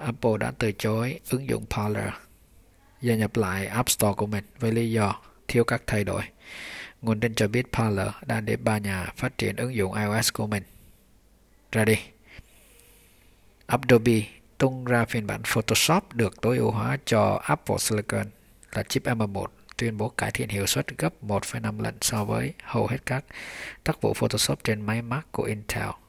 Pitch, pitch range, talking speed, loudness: 110 Hz, 100-115 Hz, 175 wpm, -26 LUFS